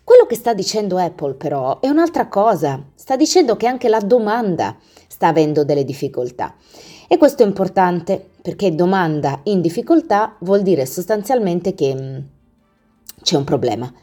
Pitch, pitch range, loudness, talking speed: 190 Hz, 150-230 Hz, -17 LUFS, 145 wpm